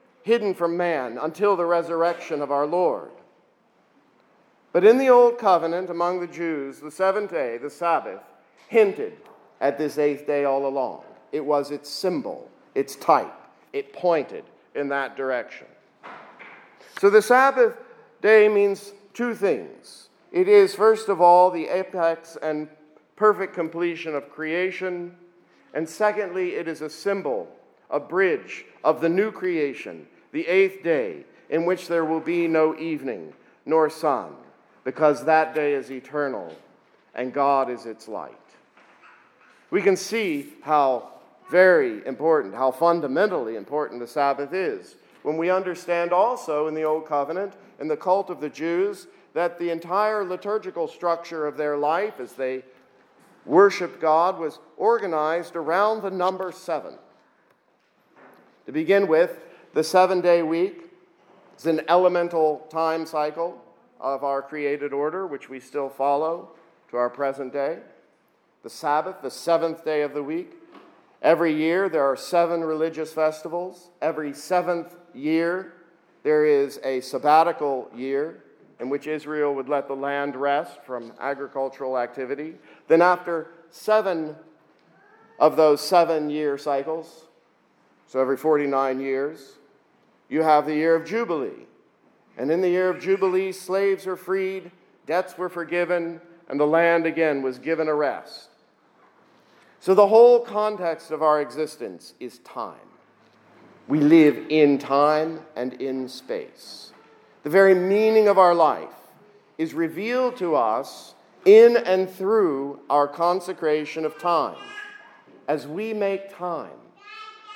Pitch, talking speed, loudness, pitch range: 165 Hz, 140 wpm, -23 LUFS, 150-195 Hz